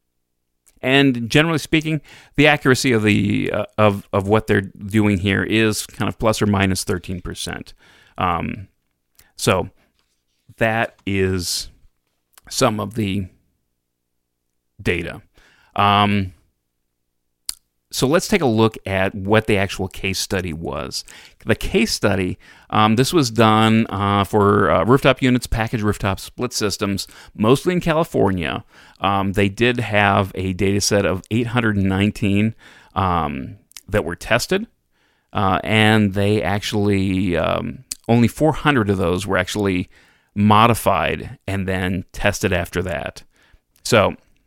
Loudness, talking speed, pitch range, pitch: -19 LUFS, 125 wpm, 90-110 Hz, 100 Hz